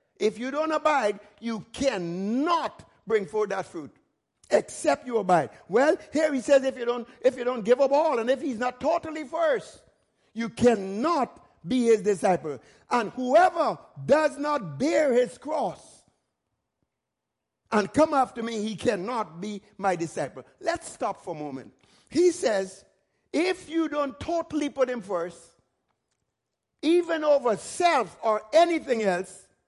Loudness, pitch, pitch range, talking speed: -26 LUFS, 245 Hz, 205-305 Hz, 150 wpm